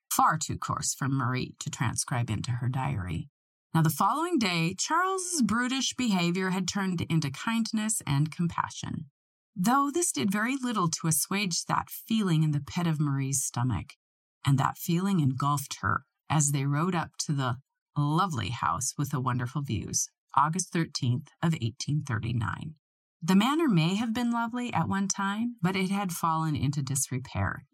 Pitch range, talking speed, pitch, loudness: 140-195 Hz, 165 wpm, 160 Hz, -29 LUFS